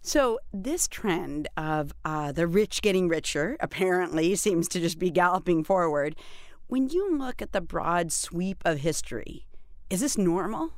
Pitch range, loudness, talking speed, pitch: 165-205 Hz, -27 LUFS, 155 wpm, 180 Hz